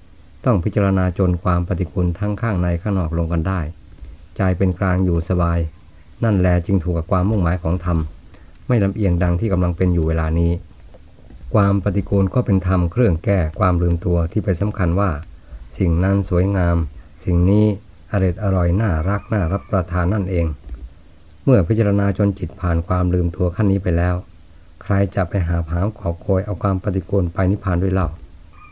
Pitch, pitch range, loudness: 90 Hz, 85-100 Hz, -19 LUFS